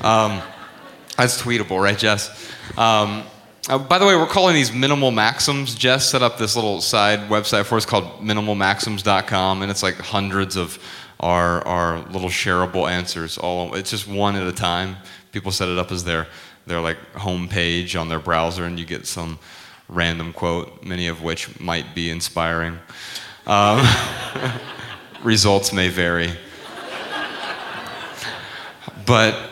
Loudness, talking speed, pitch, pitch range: -20 LUFS, 145 wpm, 95 Hz, 85-110 Hz